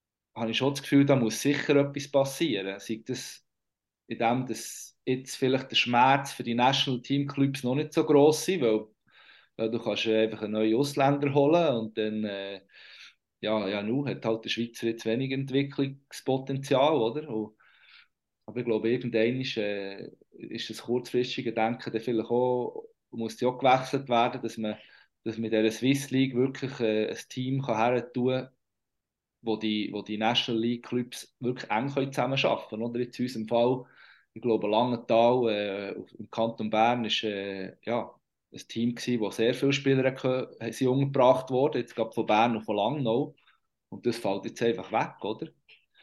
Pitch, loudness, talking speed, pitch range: 120 Hz, -28 LUFS, 170 wpm, 110-130 Hz